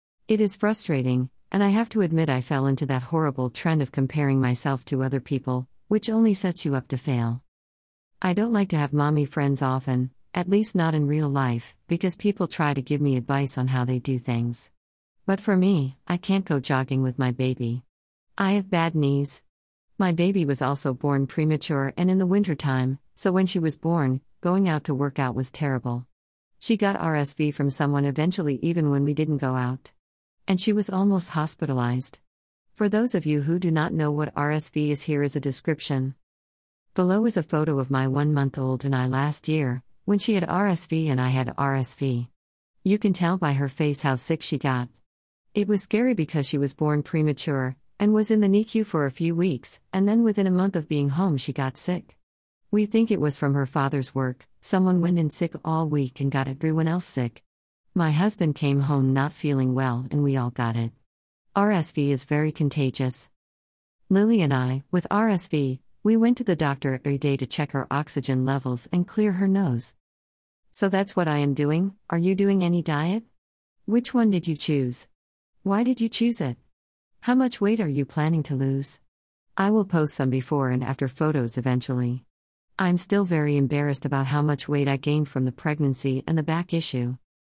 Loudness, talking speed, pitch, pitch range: -24 LUFS, 200 wpm, 145 Hz, 130-175 Hz